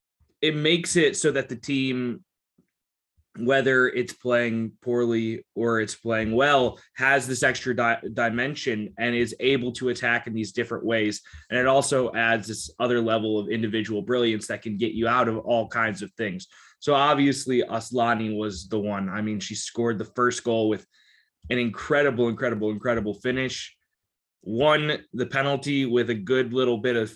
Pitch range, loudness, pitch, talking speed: 110-130 Hz, -24 LUFS, 120 Hz, 170 wpm